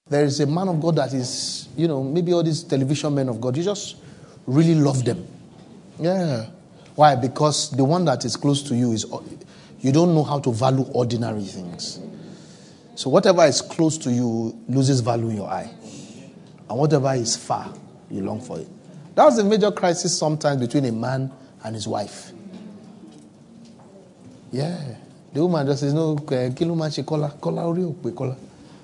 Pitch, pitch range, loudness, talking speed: 145 Hz, 130-165 Hz, -22 LUFS, 165 wpm